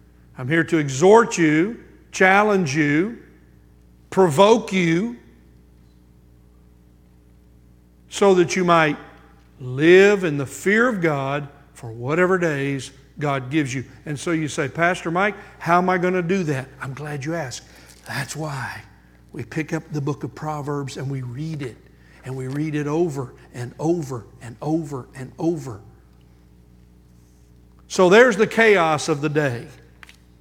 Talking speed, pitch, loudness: 145 wpm, 140 Hz, -20 LUFS